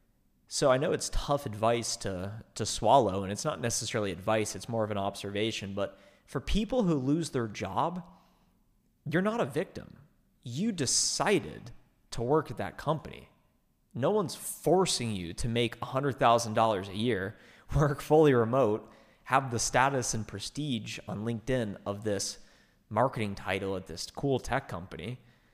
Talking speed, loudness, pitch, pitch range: 155 wpm, -30 LUFS, 115 Hz, 100-135 Hz